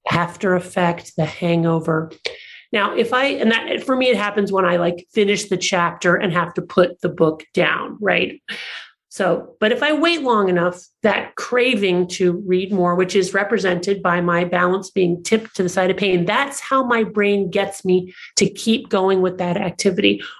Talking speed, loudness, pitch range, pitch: 190 wpm, -19 LUFS, 175-210 Hz, 185 Hz